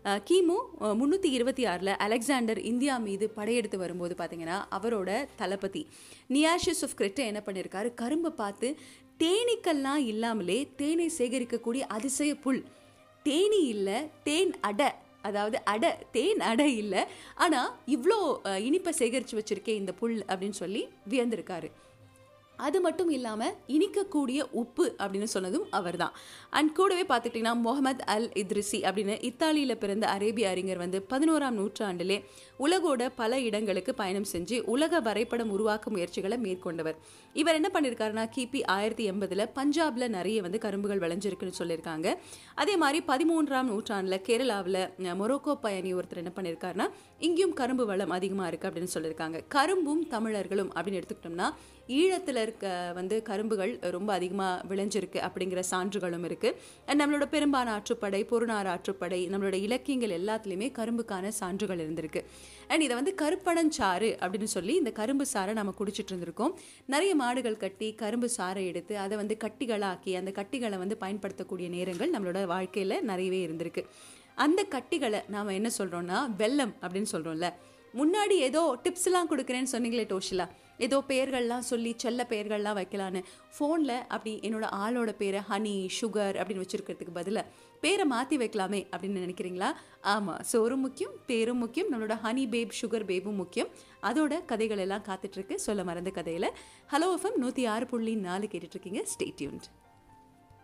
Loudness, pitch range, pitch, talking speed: -31 LUFS, 190-275 Hz, 220 Hz, 130 wpm